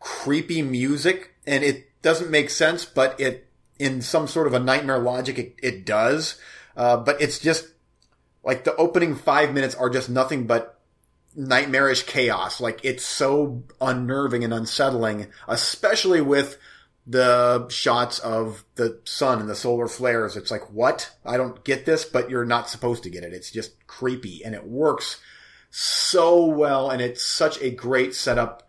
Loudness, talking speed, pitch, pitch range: -22 LUFS, 165 wpm, 130 Hz, 120-145 Hz